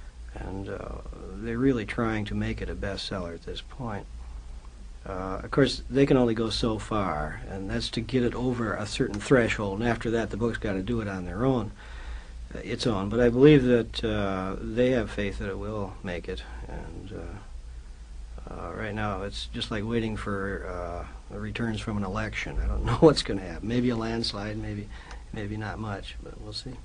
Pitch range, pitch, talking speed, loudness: 95-115 Hz, 105 Hz, 205 wpm, -28 LUFS